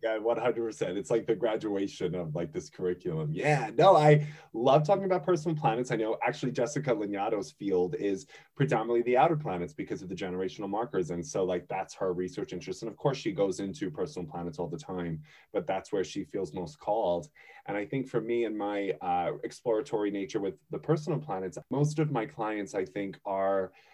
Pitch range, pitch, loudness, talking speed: 95-150 Hz, 110 Hz, -31 LUFS, 205 wpm